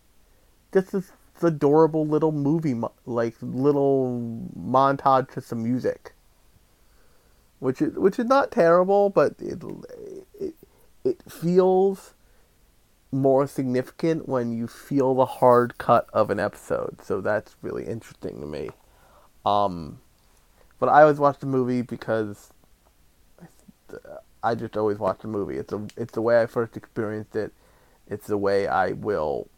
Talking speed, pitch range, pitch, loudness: 140 wpm, 115-160 Hz, 130 Hz, -23 LUFS